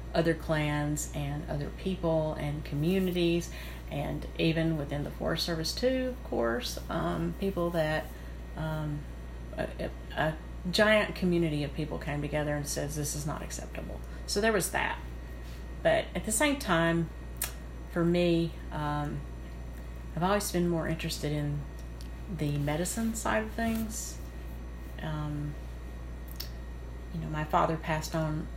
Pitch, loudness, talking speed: 150 Hz, -31 LUFS, 135 wpm